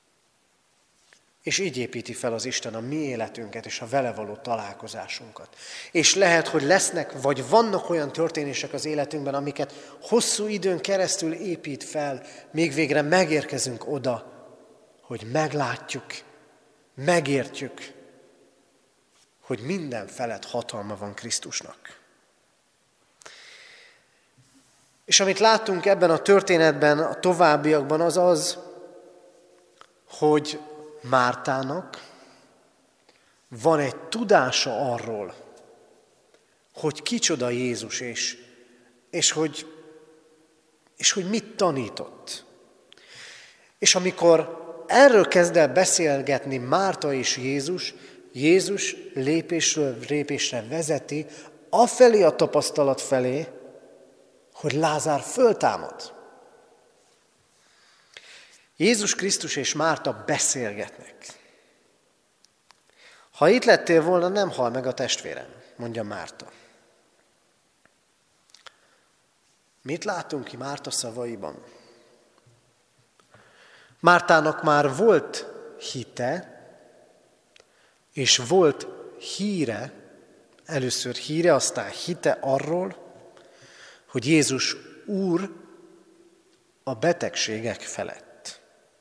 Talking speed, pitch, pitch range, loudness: 85 wpm, 155 Hz, 135-185 Hz, -23 LUFS